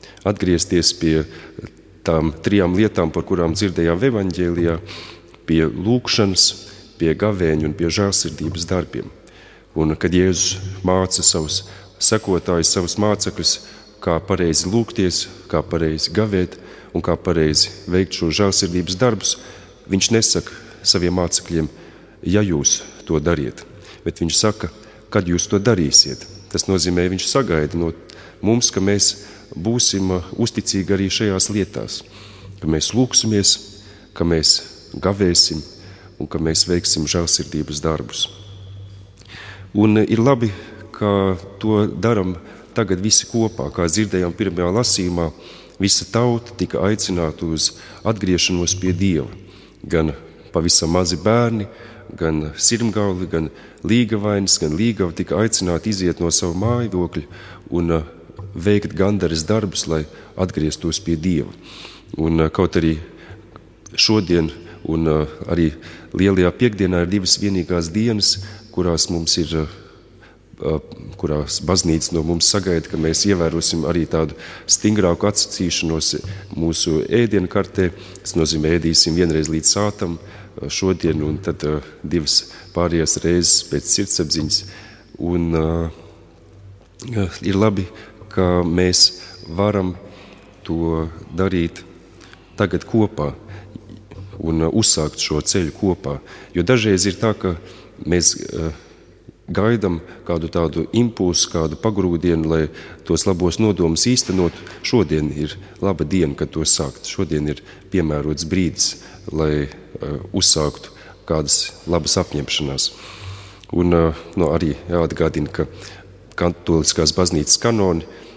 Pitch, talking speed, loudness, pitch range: 90 Hz, 110 wpm, -18 LUFS, 85-100 Hz